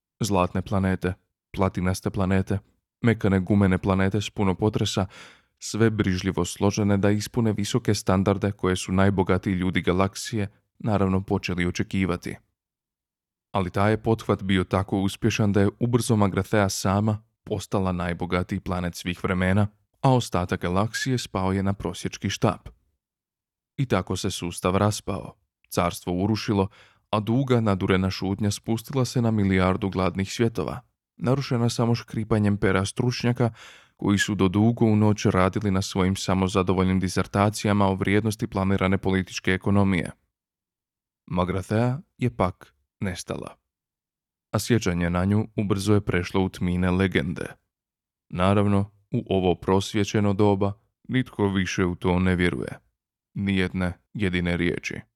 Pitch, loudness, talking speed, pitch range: 100 Hz, -24 LUFS, 125 wpm, 95-105 Hz